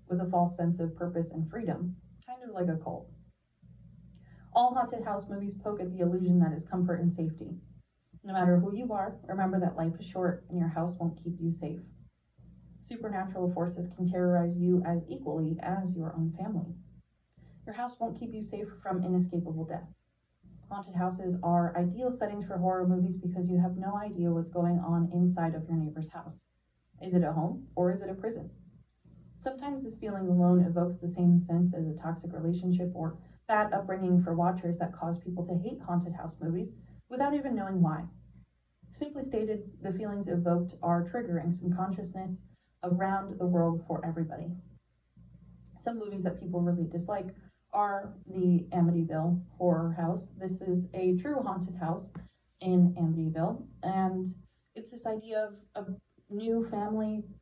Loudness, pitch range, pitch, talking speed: -32 LUFS, 170-195 Hz, 180 Hz, 170 wpm